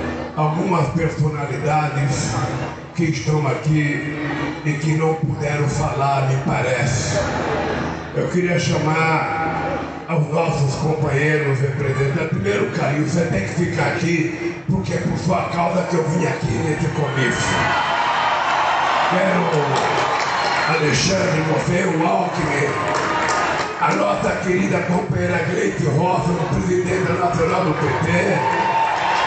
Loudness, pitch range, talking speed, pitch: -19 LUFS, 150-170 Hz, 110 wpm, 155 Hz